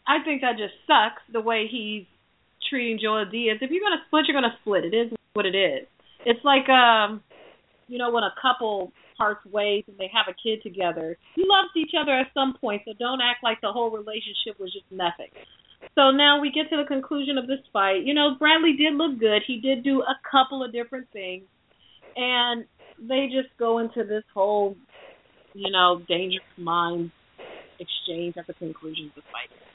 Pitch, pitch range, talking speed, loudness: 230 Hz, 200-270 Hz, 200 wpm, -23 LUFS